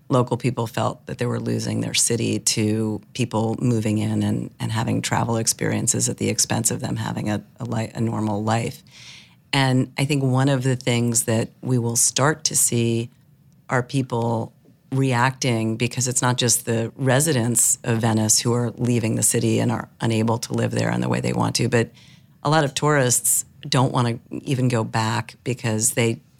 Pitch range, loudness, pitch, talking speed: 115-130 Hz, -21 LUFS, 120 Hz, 190 wpm